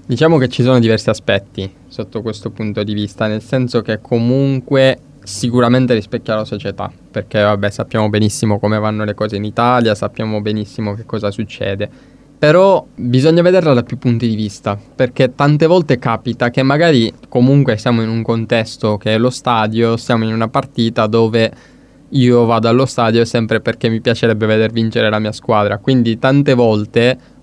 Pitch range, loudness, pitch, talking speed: 110-125 Hz, -14 LUFS, 115 Hz, 170 wpm